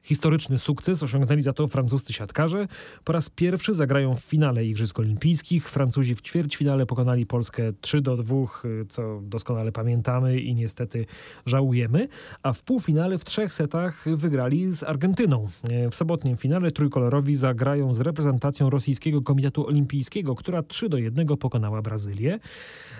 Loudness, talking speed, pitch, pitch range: -25 LUFS, 140 wpm, 140 Hz, 120-155 Hz